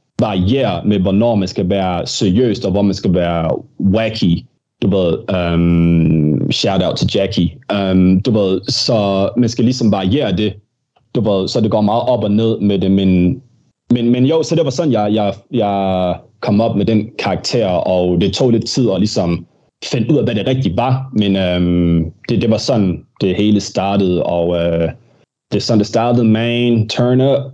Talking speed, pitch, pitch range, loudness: 200 wpm, 105 Hz, 95-120 Hz, -15 LUFS